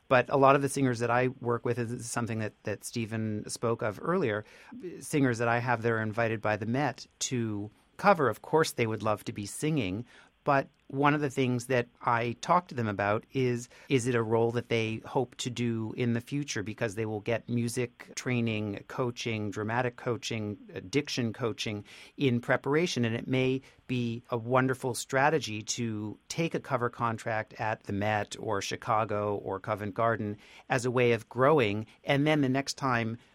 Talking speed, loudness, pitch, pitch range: 190 wpm, -30 LUFS, 120 Hz, 110-130 Hz